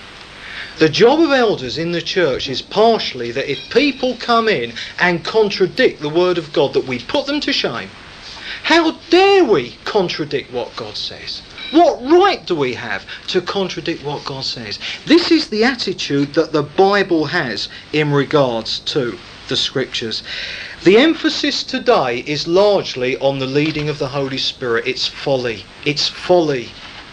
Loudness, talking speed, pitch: -16 LUFS, 160 wpm, 170 Hz